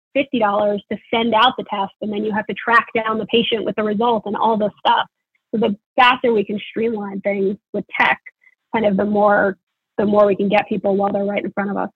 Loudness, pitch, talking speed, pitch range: -18 LUFS, 210 Hz, 245 wpm, 205-230 Hz